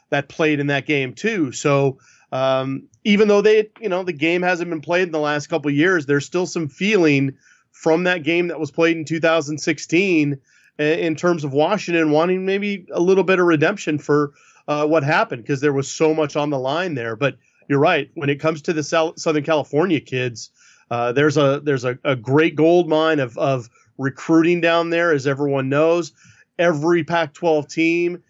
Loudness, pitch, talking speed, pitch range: -19 LUFS, 155 Hz, 195 wpm, 145-170 Hz